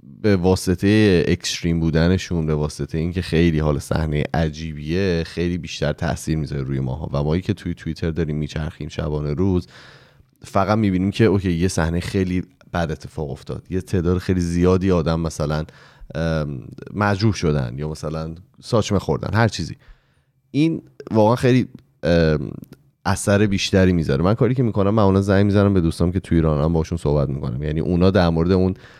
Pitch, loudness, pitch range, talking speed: 85 Hz, -20 LUFS, 80-100 Hz, 155 wpm